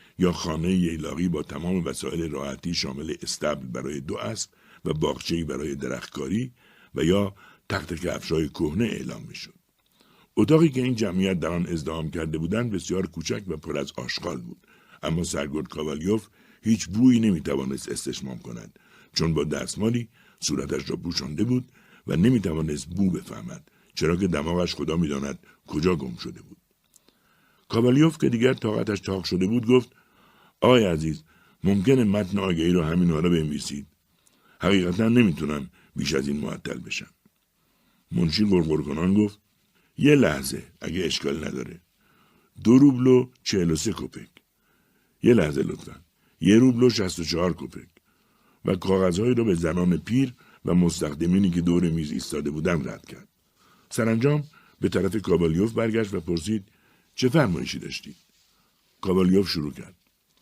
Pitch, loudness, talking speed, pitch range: 95 Hz, -25 LUFS, 140 wpm, 80-115 Hz